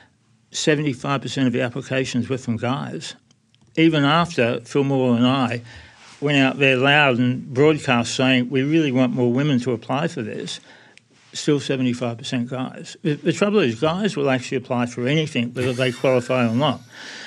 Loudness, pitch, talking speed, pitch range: -20 LUFS, 130 Hz, 160 wpm, 120-140 Hz